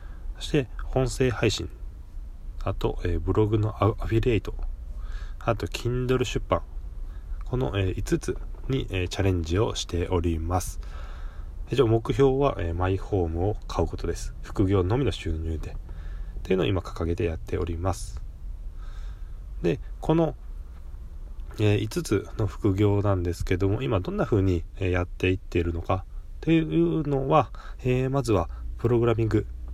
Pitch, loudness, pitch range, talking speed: 90 Hz, -26 LUFS, 80-110 Hz, 265 characters per minute